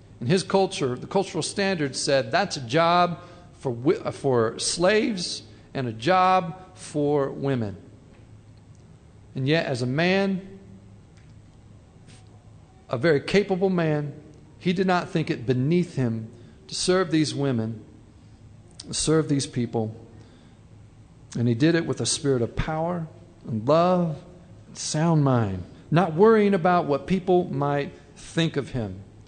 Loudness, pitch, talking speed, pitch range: -24 LUFS, 140 Hz, 135 wpm, 115-175 Hz